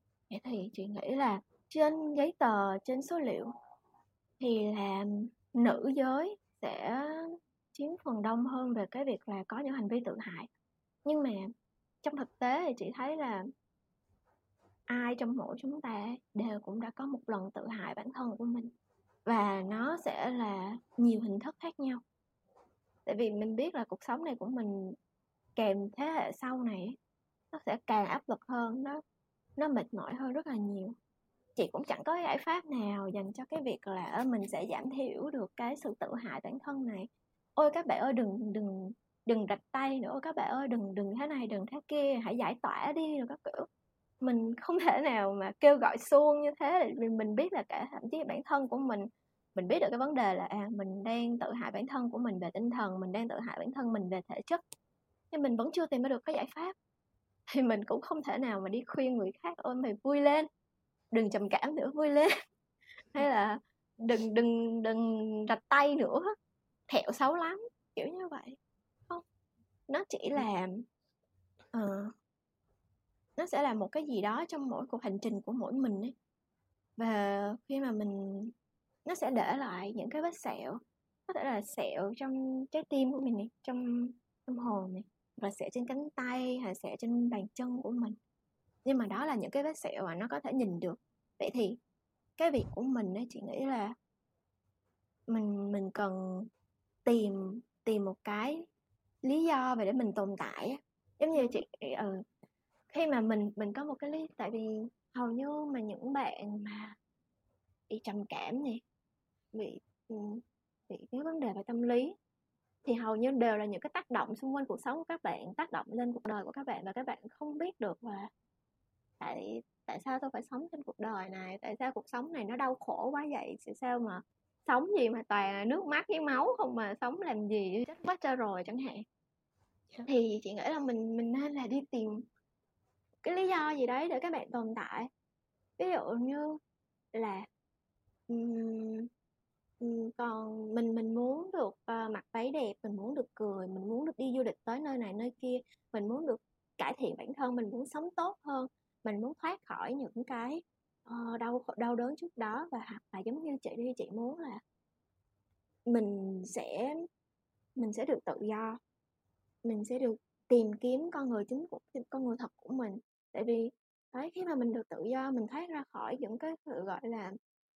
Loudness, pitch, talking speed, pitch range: -36 LUFS, 240 Hz, 200 wpm, 215-275 Hz